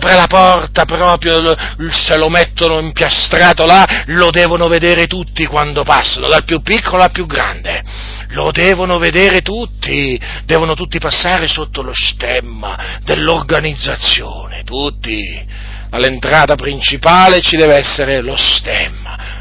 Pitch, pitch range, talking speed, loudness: 160 Hz, 130-175 Hz, 125 wpm, -10 LUFS